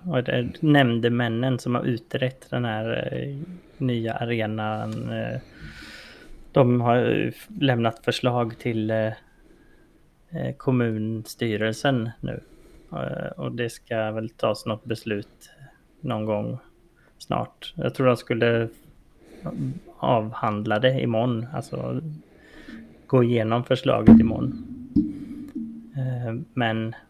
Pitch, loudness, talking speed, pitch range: 120 Hz, -24 LUFS, 85 wpm, 110-130 Hz